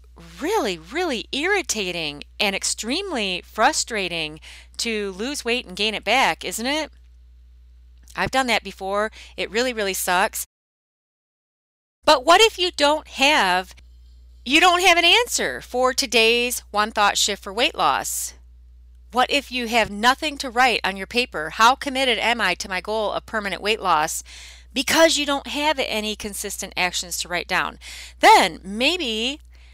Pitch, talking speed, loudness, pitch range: 210 Hz, 150 wpm, -20 LUFS, 175-260 Hz